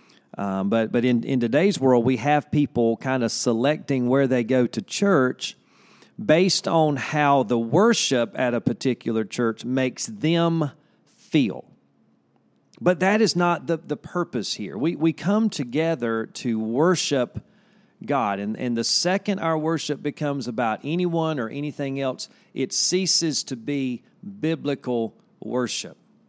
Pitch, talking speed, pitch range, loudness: 140 Hz, 145 wpm, 120-165 Hz, -23 LUFS